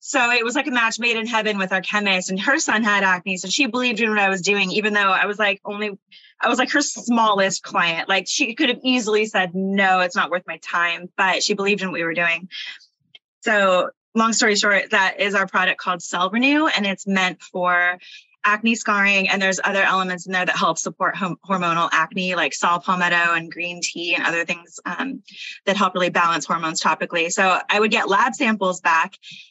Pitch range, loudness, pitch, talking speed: 180-220 Hz, -19 LUFS, 195 Hz, 220 wpm